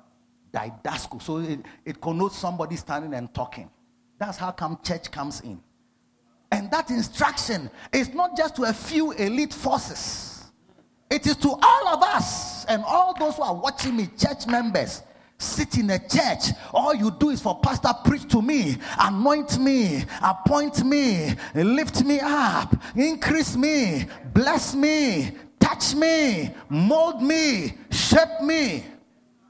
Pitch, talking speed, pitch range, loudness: 250 Hz, 145 wpm, 185-295 Hz, -22 LUFS